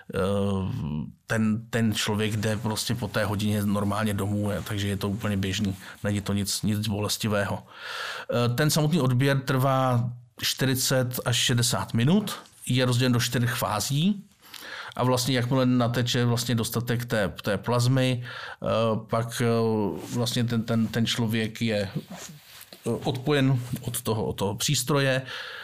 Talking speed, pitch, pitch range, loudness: 130 wpm, 115 Hz, 105-130 Hz, -26 LUFS